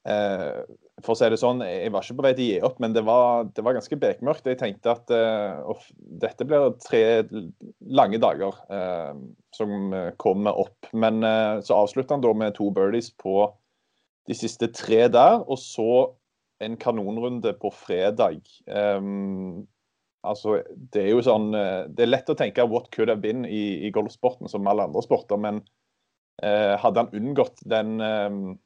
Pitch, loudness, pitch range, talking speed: 110 Hz, -24 LUFS, 100-115 Hz, 180 wpm